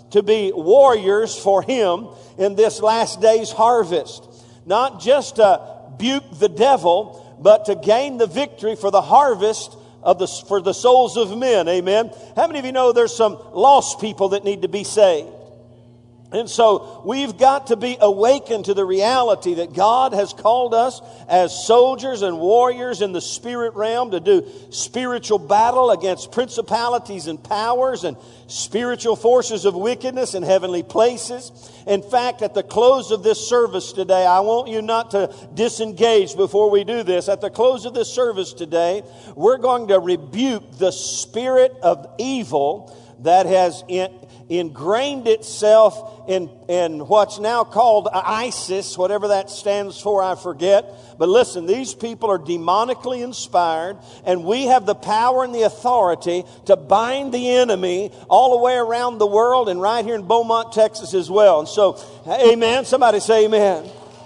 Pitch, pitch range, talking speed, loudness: 215 Hz, 190-245 Hz, 165 wpm, -18 LUFS